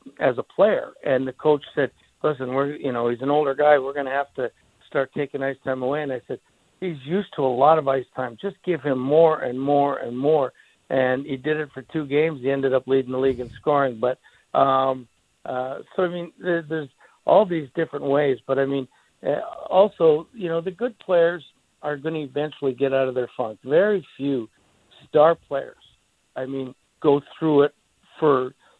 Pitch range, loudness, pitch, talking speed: 130-160 Hz, -23 LUFS, 140 Hz, 205 wpm